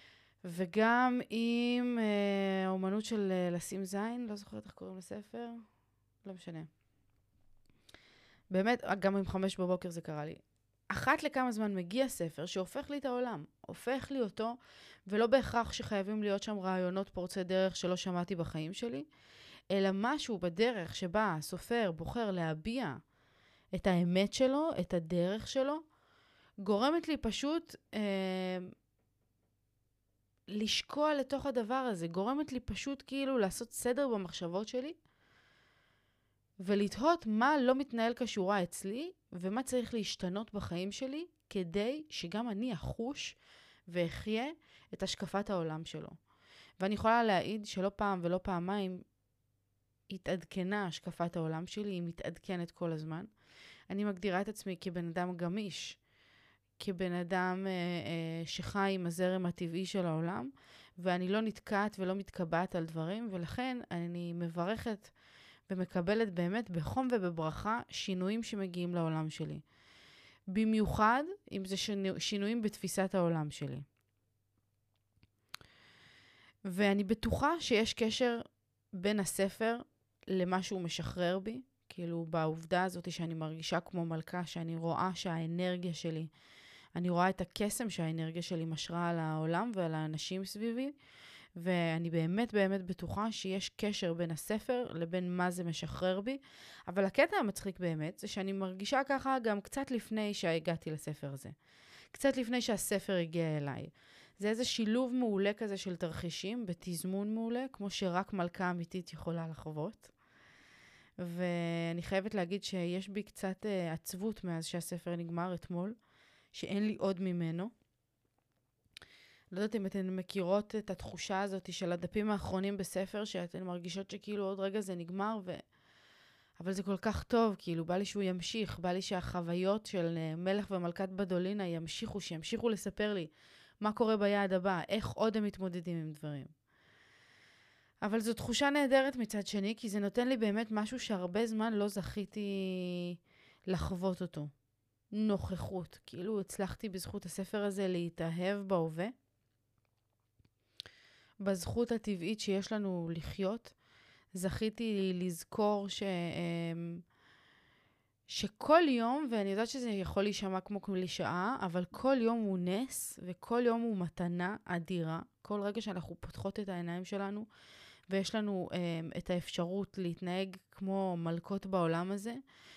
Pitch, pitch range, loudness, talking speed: 190 Hz, 170-215 Hz, -36 LUFS, 130 wpm